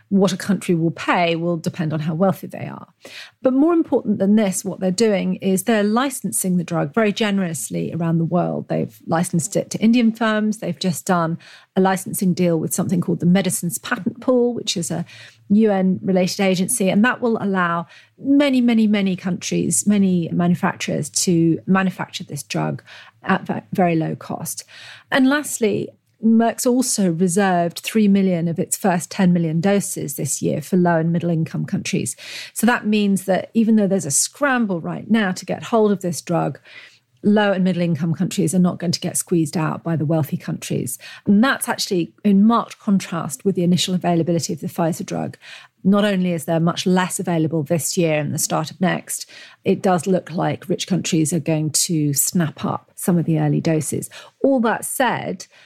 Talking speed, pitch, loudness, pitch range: 190 wpm, 185 Hz, -19 LUFS, 170-205 Hz